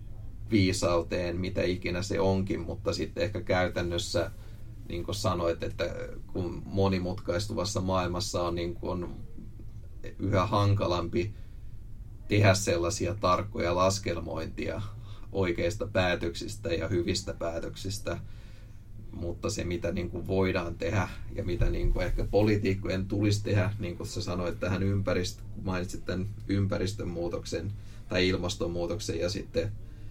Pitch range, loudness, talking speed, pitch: 90-105 Hz, -30 LUFS, 115 wpm, 95 Hz